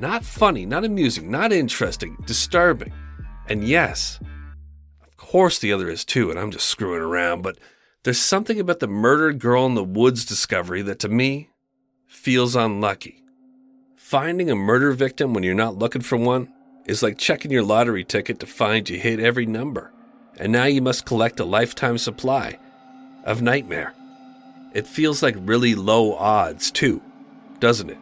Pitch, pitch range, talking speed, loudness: 125 Hz, 110-165 Hz, 165 wpm, -20 LUFS